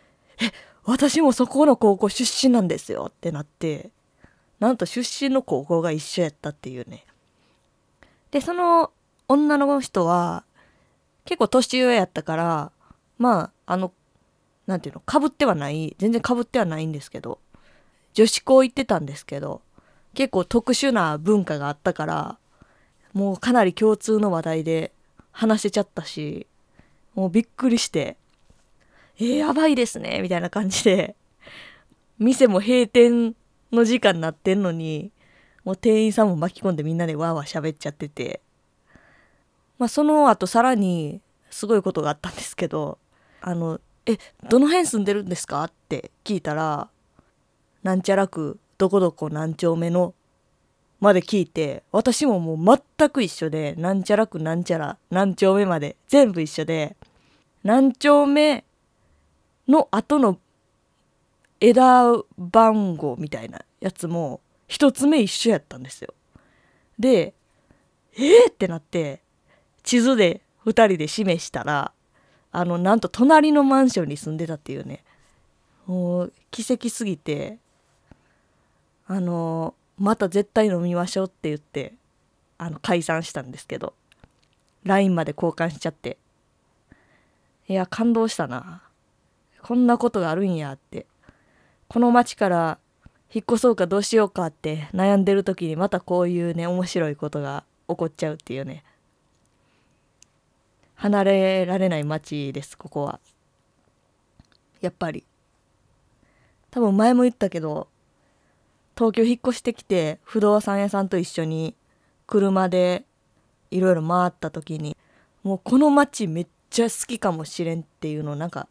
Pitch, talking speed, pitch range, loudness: 190 Hz, 275 characters per minute, 165-235 Hz, -21 LUFS